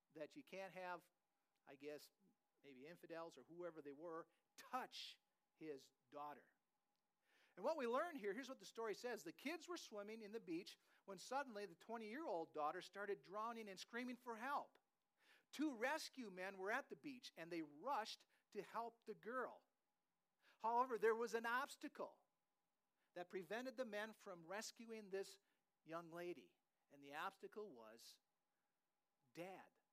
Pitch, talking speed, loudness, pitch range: 205 Hz, 155 wpm, -51 LUFS, 175-240 Hz